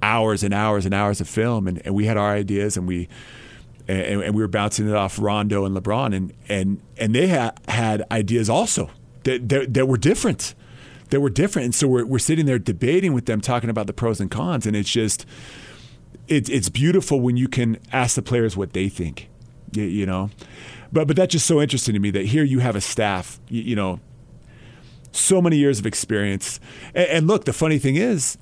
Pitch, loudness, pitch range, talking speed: 115 Hz, -21 LUFS, 105-130 Hz, 215 wpm